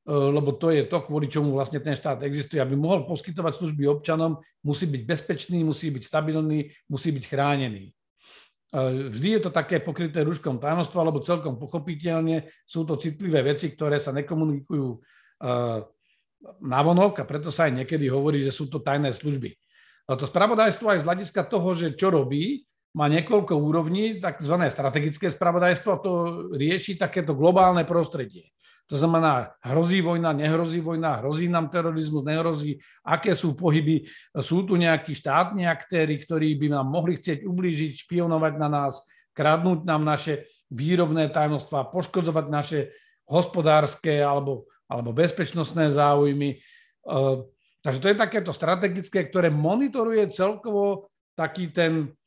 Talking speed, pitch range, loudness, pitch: 140 wpm, 145-175 Hz, -25 LUFS, 160 Hz